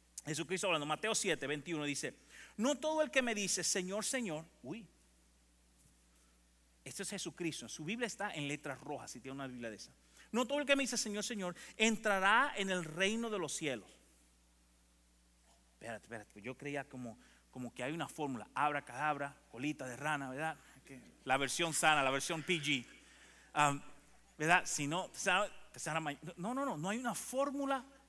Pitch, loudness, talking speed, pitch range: 150 Hz, -37 LUFS, 165 wpm, 125-200 Hz